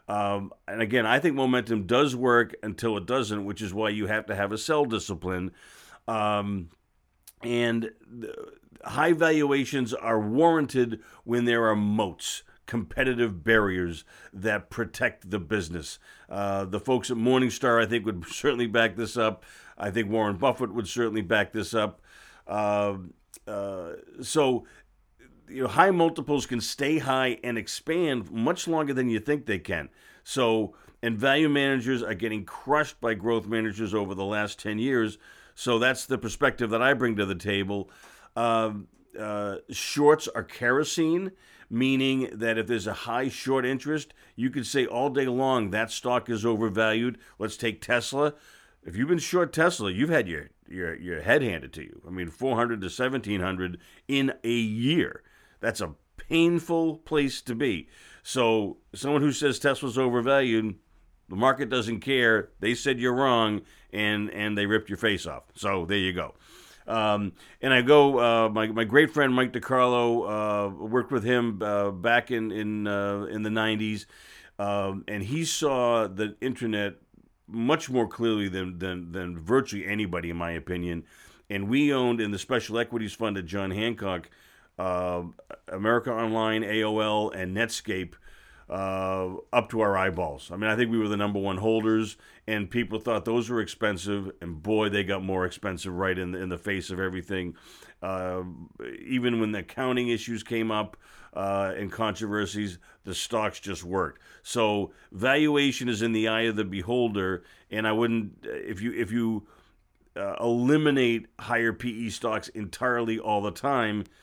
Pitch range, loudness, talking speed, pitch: 100-125 Hz, -27 LUFS, 165 wpm, 110 Hz